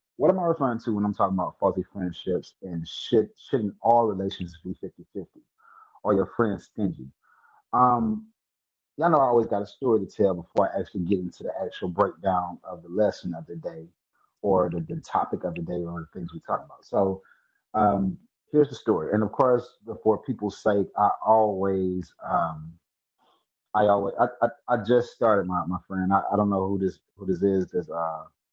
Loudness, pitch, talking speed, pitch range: -26 LUFS, 95 Hz, 200 wpm, 90-110 Hz